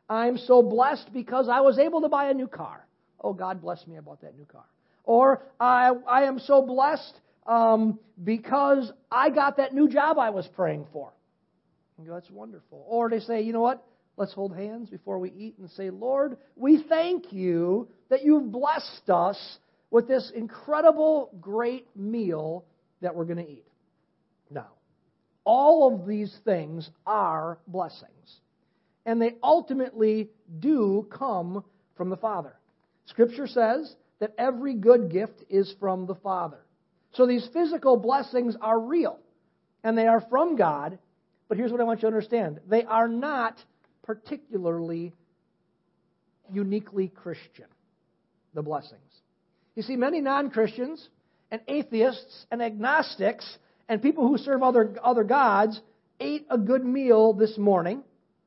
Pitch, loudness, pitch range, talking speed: 225 Hz, -25 LUFS, 190-260 Hz, 150 wpm